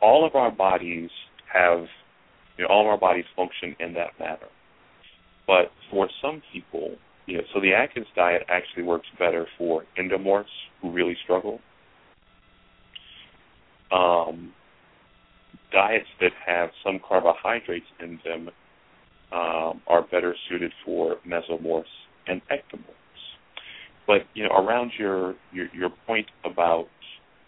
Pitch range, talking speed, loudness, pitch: 85-90 Hz, 125 wpm, -24 LUFS, 85 Hz